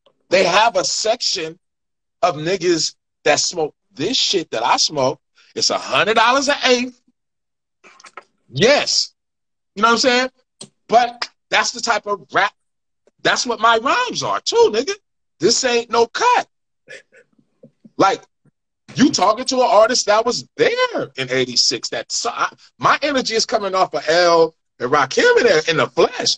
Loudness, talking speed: -17 LUFS, 150 wpm